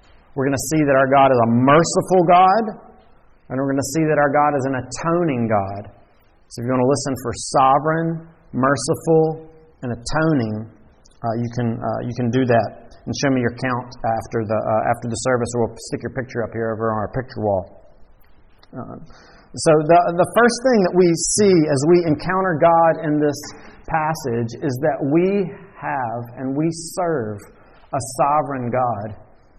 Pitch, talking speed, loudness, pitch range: 135 Hz, 185 wpm, -19 LUFS, 115-160 Hz